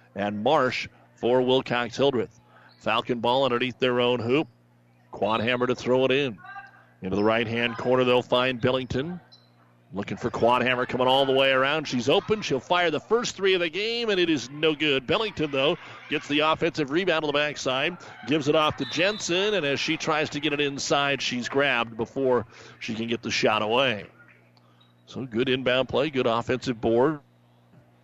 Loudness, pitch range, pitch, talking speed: -24 LUFS, 115-150 Hz, 130 Hz, 185 wpm